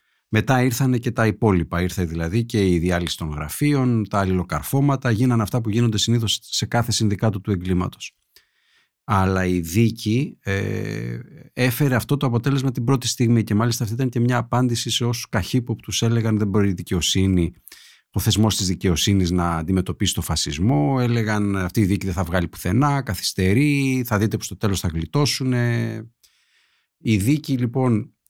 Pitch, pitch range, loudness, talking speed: 110 Hz, 95-120 Hz, -21 LUFS, 165 wpm